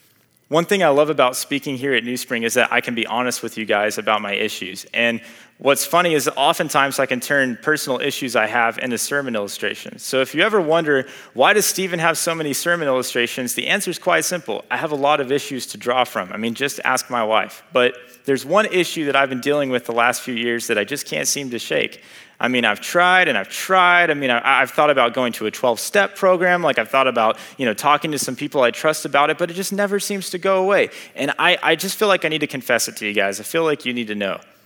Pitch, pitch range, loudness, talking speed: 140 Hz, 125-165 Hz, -19 LUFS, 260 wpm